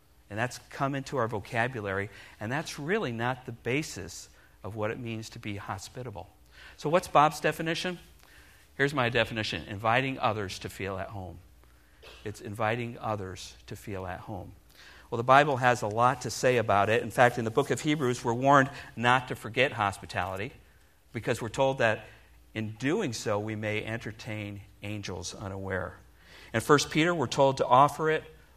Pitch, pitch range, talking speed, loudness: 115 Hz, 100-130 Hz, 170 wpm, -29 LUFS